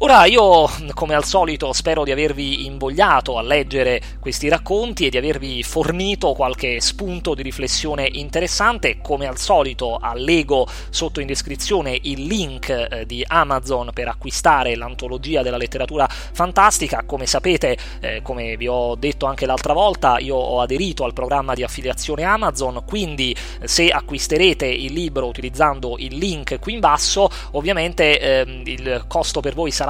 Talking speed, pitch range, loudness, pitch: 155 wpm, 130-165 Hz, -19 LUFS, 140 Hz